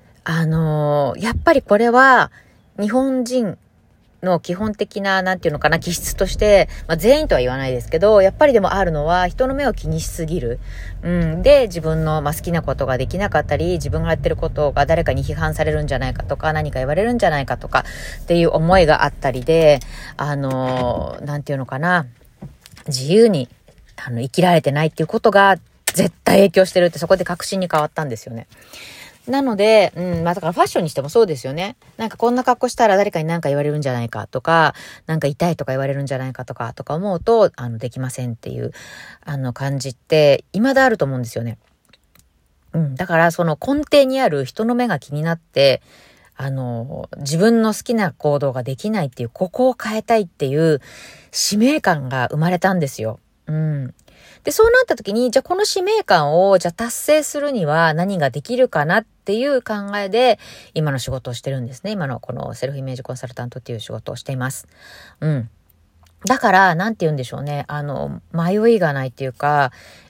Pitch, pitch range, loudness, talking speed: 160 Hz, 135-200 Hz, -18 LUFS, 405 characters per minute